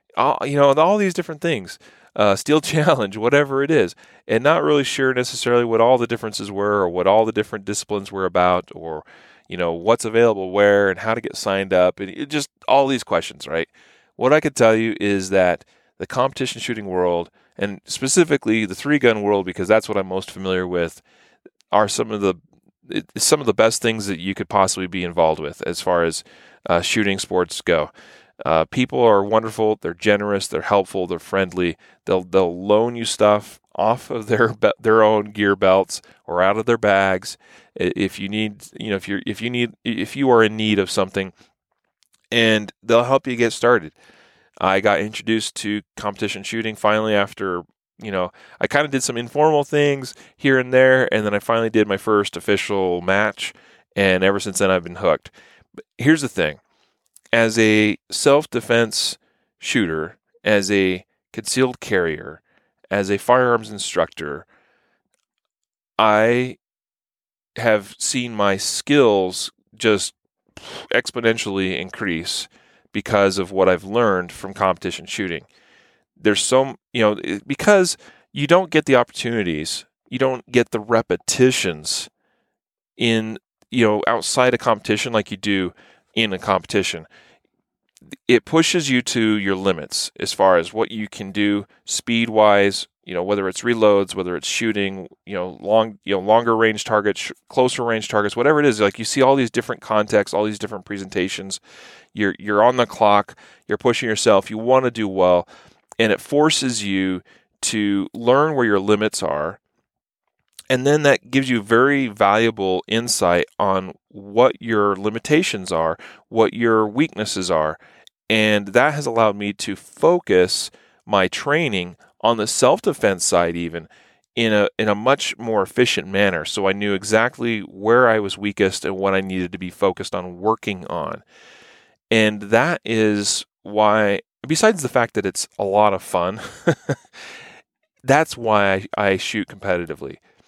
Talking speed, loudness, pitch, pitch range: 165 wpm, -19 LUFS, 105 Hz, 95-120 Hz